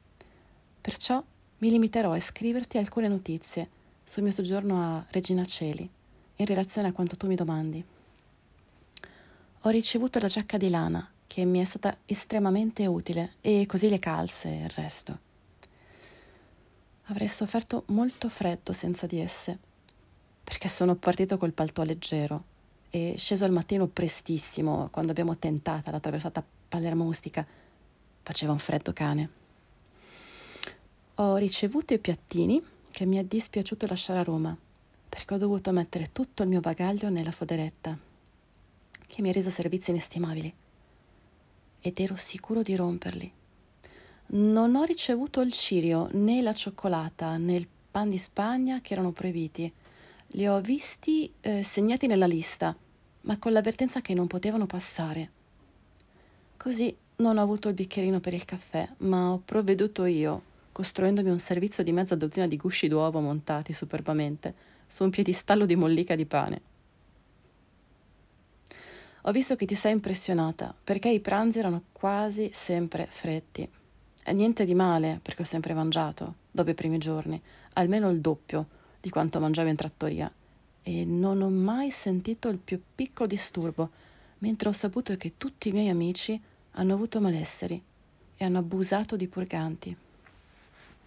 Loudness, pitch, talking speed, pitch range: -29 LUFS, 180 Hz, 145 wpm, 165-205 Hz